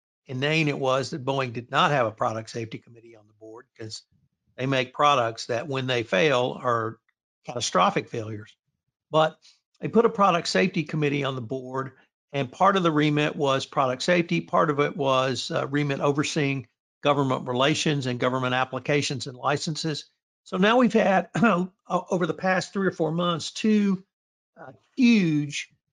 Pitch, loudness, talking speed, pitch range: 145 Hz, -24 LUFS, 170 wpm, 130-170 Hz